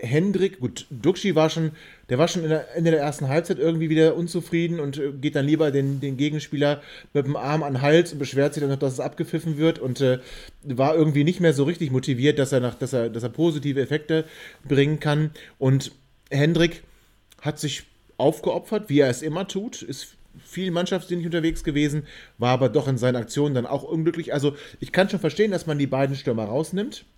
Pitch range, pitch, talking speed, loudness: 140-165 Hz, 150 Hz, 205 wpm, -23 LUFS